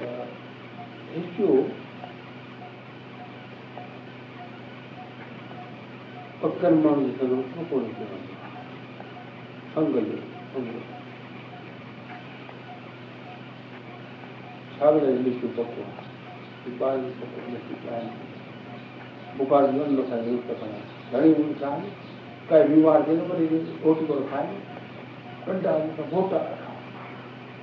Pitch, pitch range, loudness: 140 Hz, 120-155 Hz, -25 LUFS